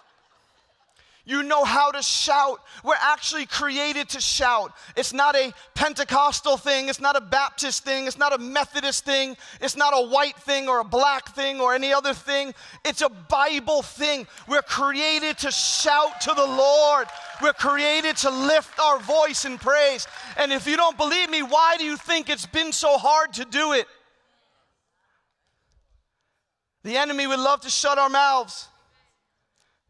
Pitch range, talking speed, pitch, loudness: 275-295 Hz, 165 wpm, 285 Hz, -22 LUFS